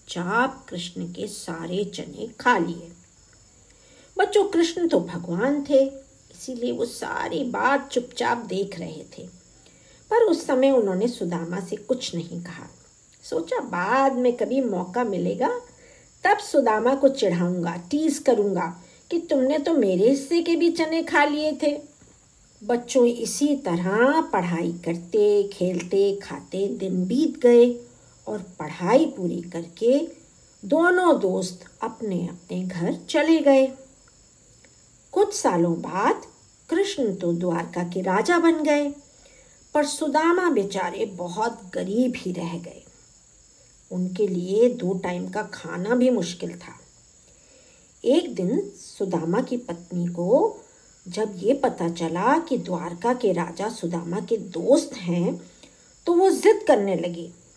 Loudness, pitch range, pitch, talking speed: -23 LUFS, 180-290 Hz, 230 Hz, 130 wpm